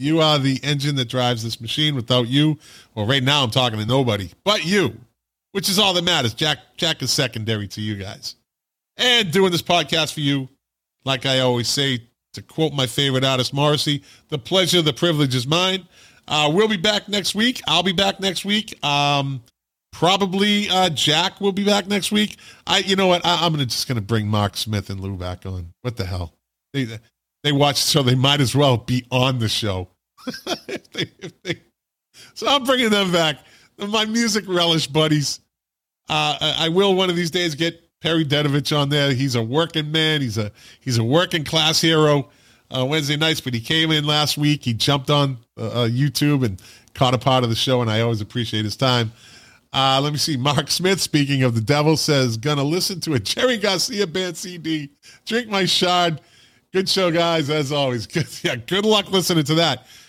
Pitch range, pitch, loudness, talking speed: 125-175 Hz, 145 Hz, -19 LUFS, 205 wpm